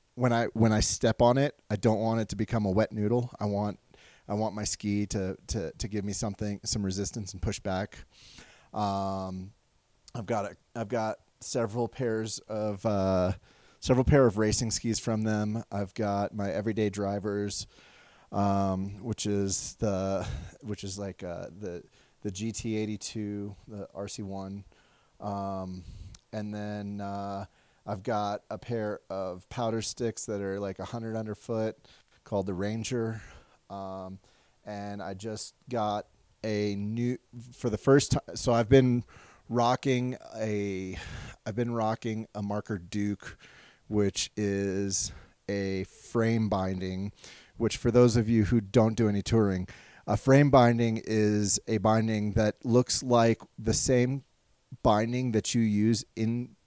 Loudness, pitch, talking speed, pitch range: -29 LUFS, 105 Hz, 155 wpm, 100-115 Hz